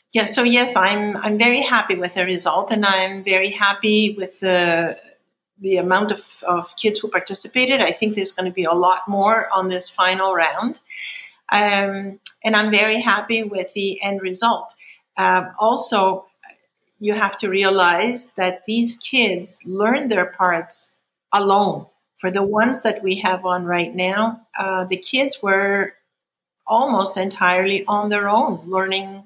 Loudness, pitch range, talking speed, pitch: -18 LUFS, 185-215 Hz, 160 wpm, 195 Hz